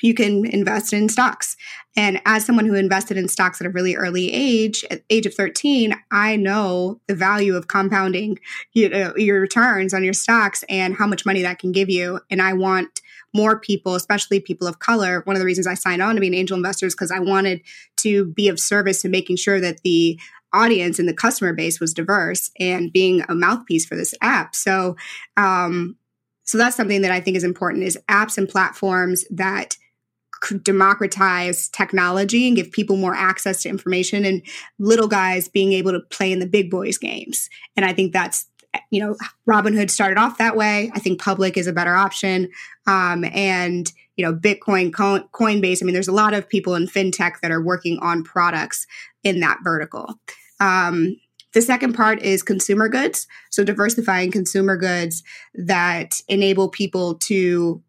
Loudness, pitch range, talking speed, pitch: -19 LUFS, 180-205 Hz, 190 wpm, 195 Hz